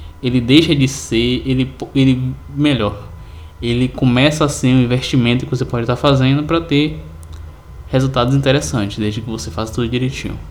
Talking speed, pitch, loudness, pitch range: 160 wpm, 125 Hz, -16 LUFS, 110-135 Hz